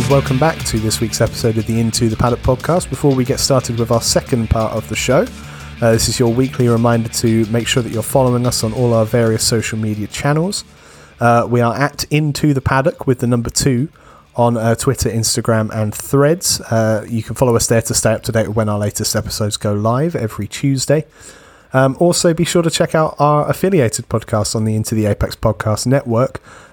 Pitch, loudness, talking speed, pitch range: 120 Hz, -16 LUFS, 220 wpm, 110-135 Hz